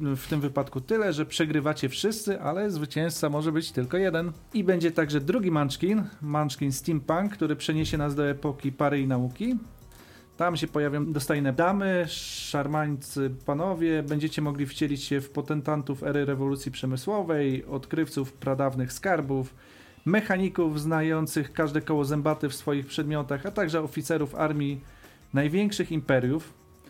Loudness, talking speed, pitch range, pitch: -28 LUFS, 135 wpm, 140-165 Hz, 150 Hz